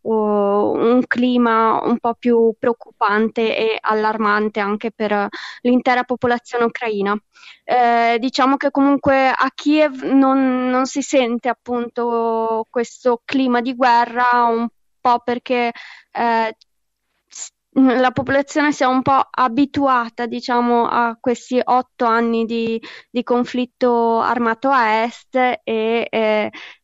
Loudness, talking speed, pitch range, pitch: -18 LUFS, 115 wpm, 230-255 Hz, 240 Hz